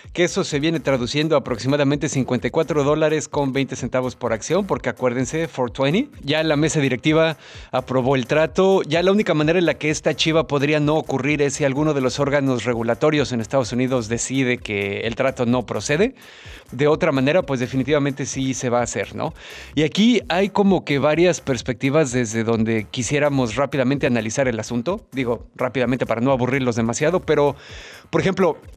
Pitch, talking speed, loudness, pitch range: 140 Hz, 180 wpm, -20 LUFS, 125-155 Hz